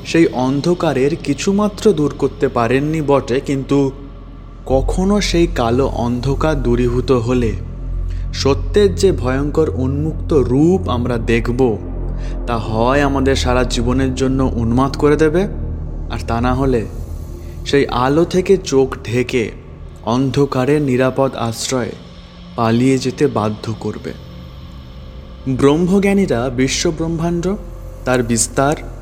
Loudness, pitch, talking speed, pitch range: -16 LUFS, 130 Hz, 105 wpm, 110-140 Hz